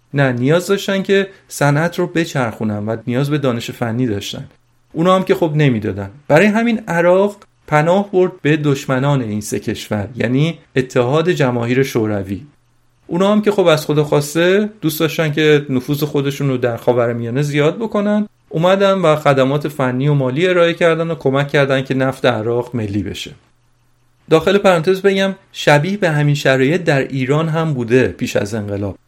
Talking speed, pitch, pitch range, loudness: 165 wpm, 145 Hz, 125-170 Hz, -16 LUFS